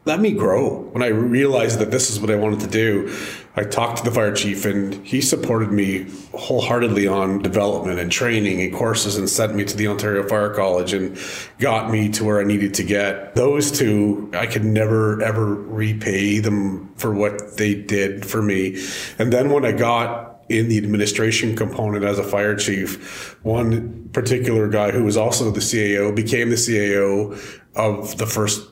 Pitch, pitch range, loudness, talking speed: 105 Hz, 100-110 Hz, -20 LUFS, 185 wpm